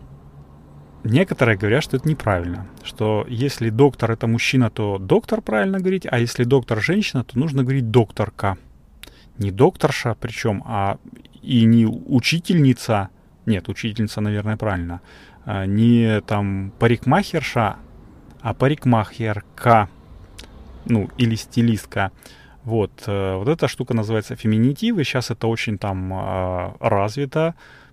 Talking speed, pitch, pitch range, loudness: 115 wpm, 115 Hz, 100-130 Hz, -20 LUFS